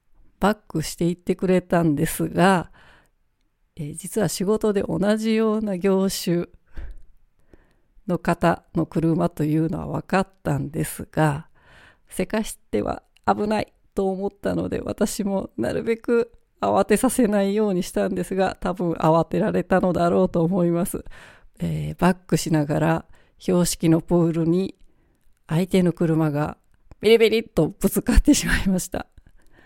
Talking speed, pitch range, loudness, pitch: 275 characters per minute, 165-200 Hz, -22 LUFS, 185 Hz